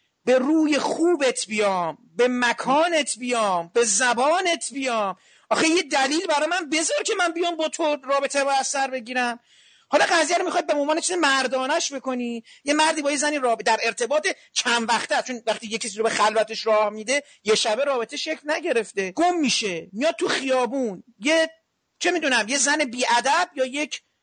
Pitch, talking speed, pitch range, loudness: 270 Hz, 170 wpm, 235-315 Hz, -22 LUFS